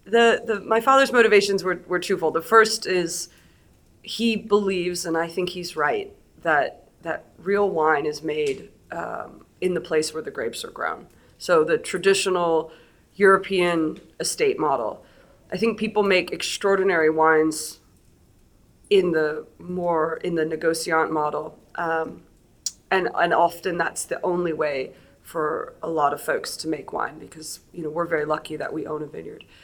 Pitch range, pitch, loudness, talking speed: 155-195 Hz, 175 Hz, -23 LUFS, 160 wpm